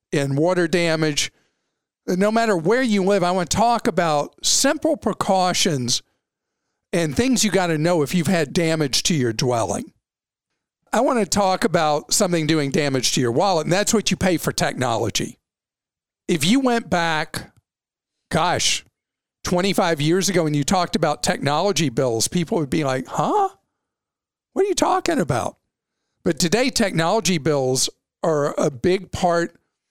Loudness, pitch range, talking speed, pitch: -20 LUFS, 155-210 Hz, 155 wpm, 180 Hz